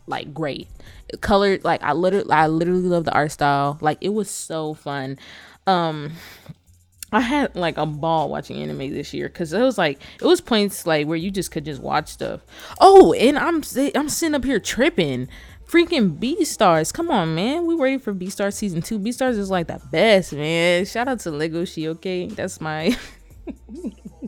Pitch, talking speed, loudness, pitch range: 185 Hz, 195 wpm, -20 LUFS, 155-235 Hz